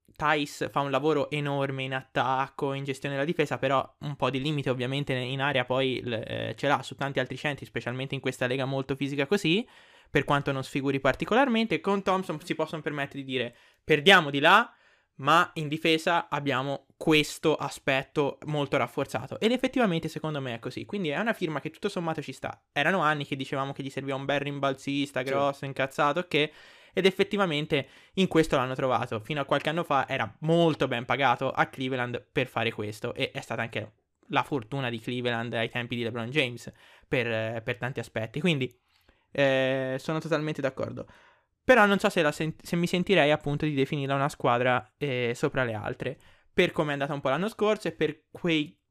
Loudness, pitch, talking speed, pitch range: -28 LUFS, 140 Hz, 190 wpm, 130-160 Hz